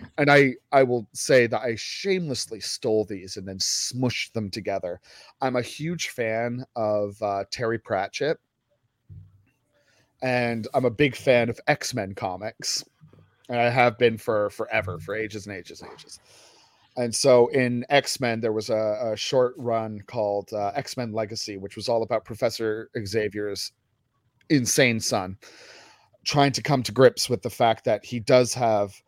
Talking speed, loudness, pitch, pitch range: 165 wpm, -24 LUFS, 115 Hz, 105-125 Hz